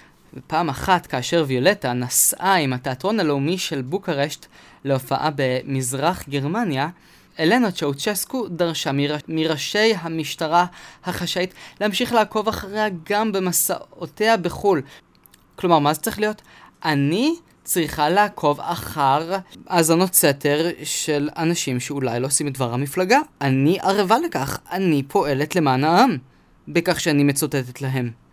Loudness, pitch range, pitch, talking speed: -21 LUFS, 140-190 Hz, 160 Hz, 120 wpm